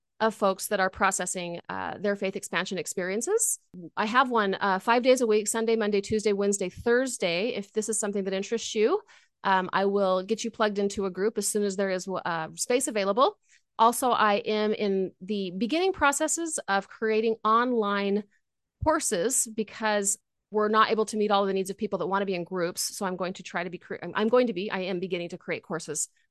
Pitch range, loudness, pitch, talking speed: 190-230 Hz, -27 LUFS, 205 Hz, 210 wpm